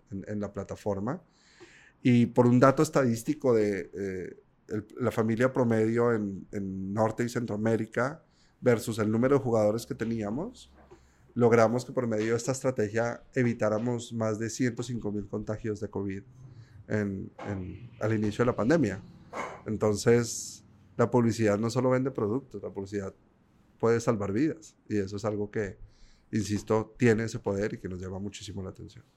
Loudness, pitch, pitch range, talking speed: -29 LUFS, 110 Hz, 105-120 Hz, 160 wpm